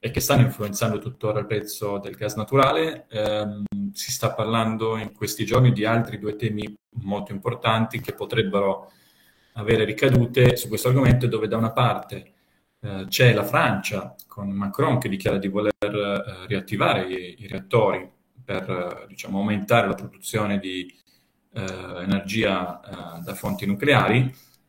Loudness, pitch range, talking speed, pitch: -23 LUFS, 100-120 Hz, 150 wpm, 105 Hz